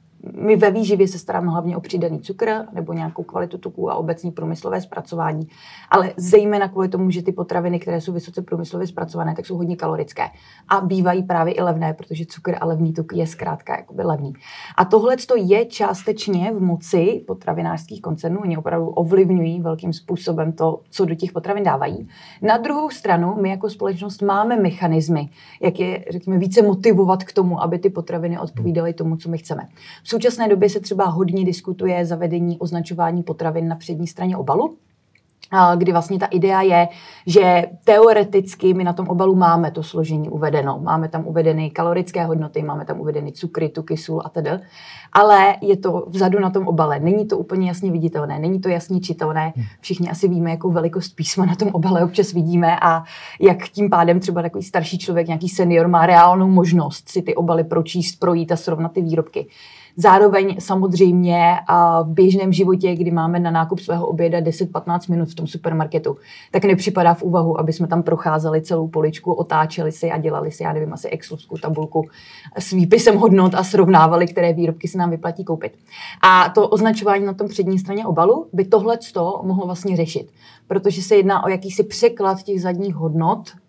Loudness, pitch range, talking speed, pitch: -18 LUFS, 165-190 Hz, 180 wpm, 175 Hz